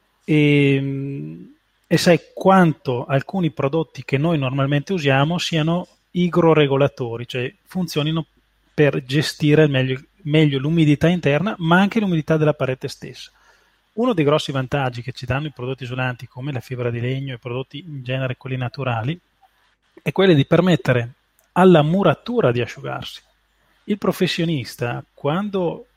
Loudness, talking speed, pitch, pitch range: -19 LUFS, 135 wpm, 145 Hz, 130-170 Hz